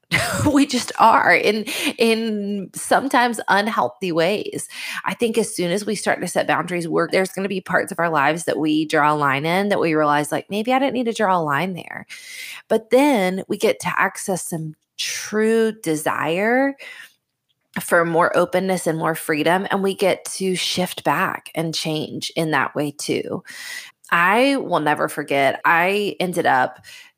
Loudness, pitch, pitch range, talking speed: -20 LUFS, 185 Hz, 160-230 Hz, 175 wpm